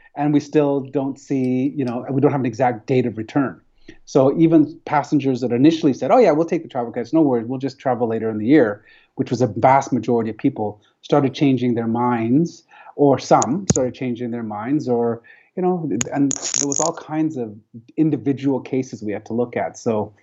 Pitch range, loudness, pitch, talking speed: 120-145 Hz, -19 LUFS, 130 Hz, 210 wpm